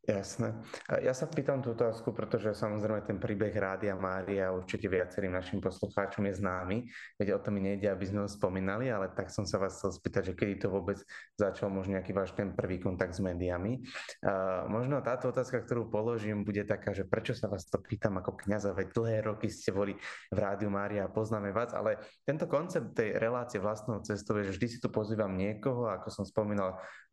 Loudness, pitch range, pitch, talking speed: -34 LUFS, 95-110 Hz, 105 Hz, 200 wpm